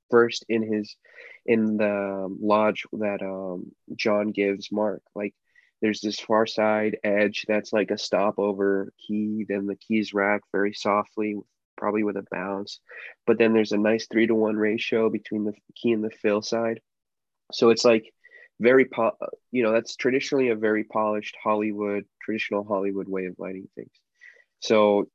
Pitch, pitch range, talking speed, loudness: 105 Hz, 100-110 Hz, 160 wpm, -25 LUFS